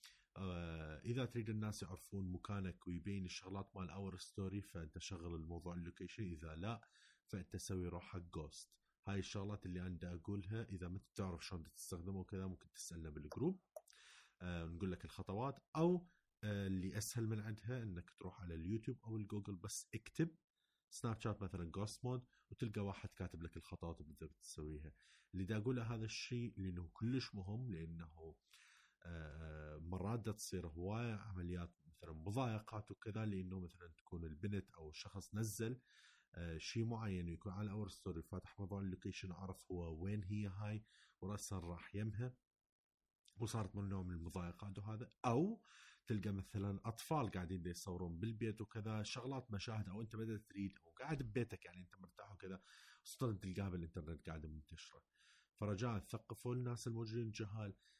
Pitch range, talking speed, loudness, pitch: 90-110 Hz, 145 wpm, -48 LUFS, 100 Hz